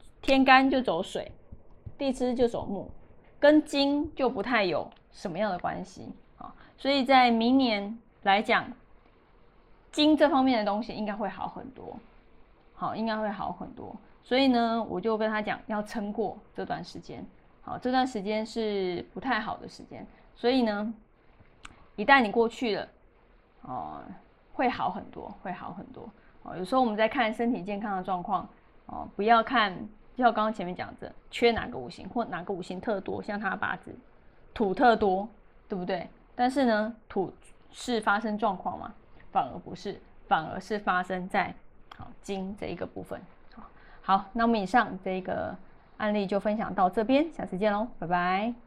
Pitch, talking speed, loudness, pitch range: 220 Hz, 240 characters per minute, -28 LUFS, 205-245 Hz